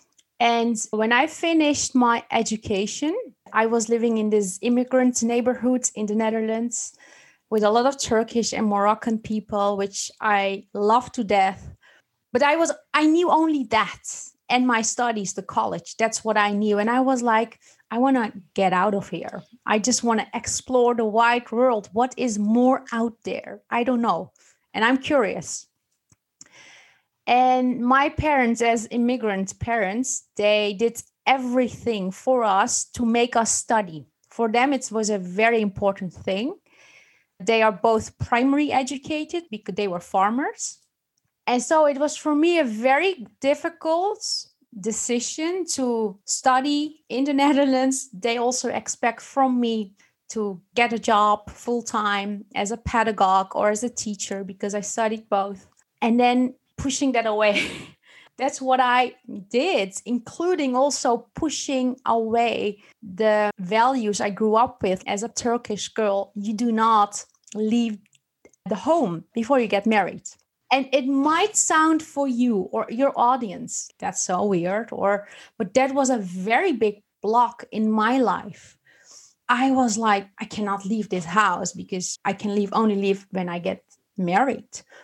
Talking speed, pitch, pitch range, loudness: 155 wpm, 230 Hz, 210-255 Hz, -22 LUFS